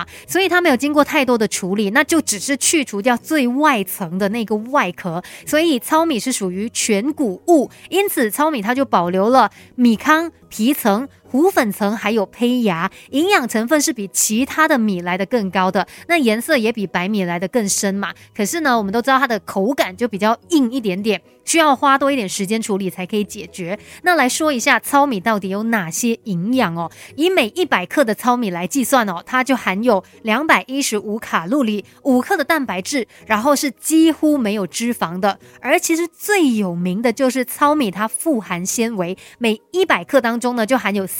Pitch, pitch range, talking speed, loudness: 235 Hz, 200-290 Hz, 290 characters per minute, -17 LUFS